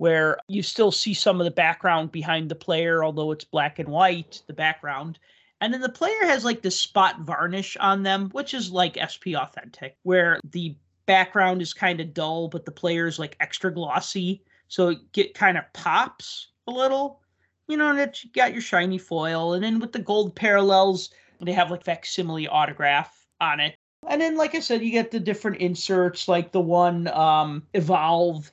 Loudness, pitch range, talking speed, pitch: -23 LUFS, 165-205 Hz, 195 wpm, 180 Hz